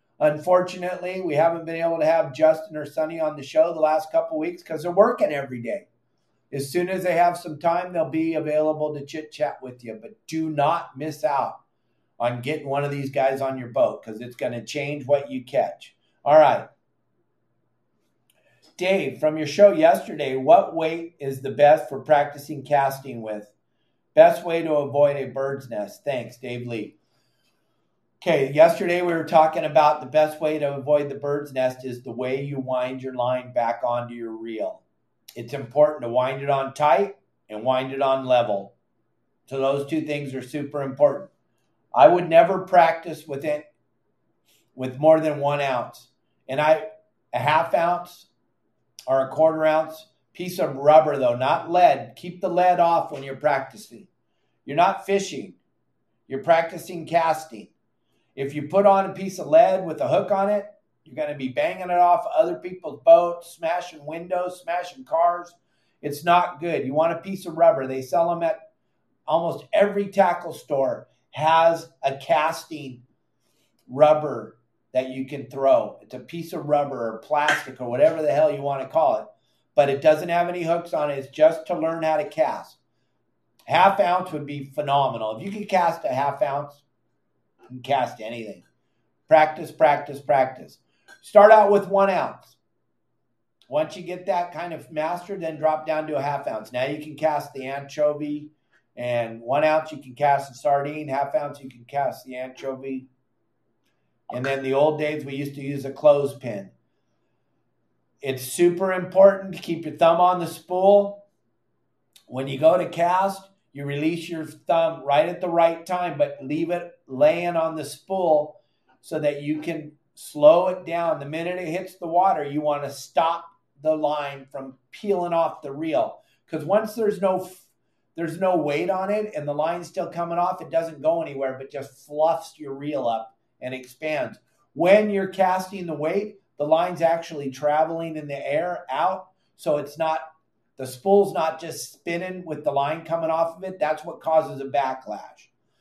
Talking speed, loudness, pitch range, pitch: 180 wpm, -22 LUFS, 140-175 Hz, 155 Hz